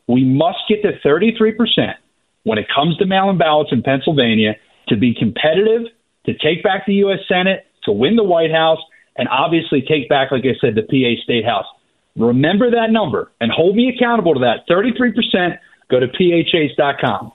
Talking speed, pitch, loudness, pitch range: 175 wpm, 170 Hz, -15 LUFS, 135-220 Hz